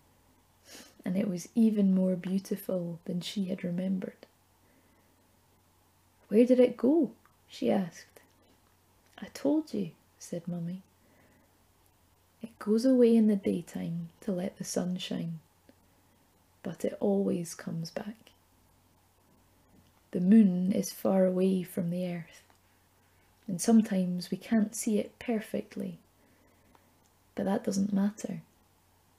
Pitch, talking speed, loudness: 180 Hz, 115 wpm, -30 LUFS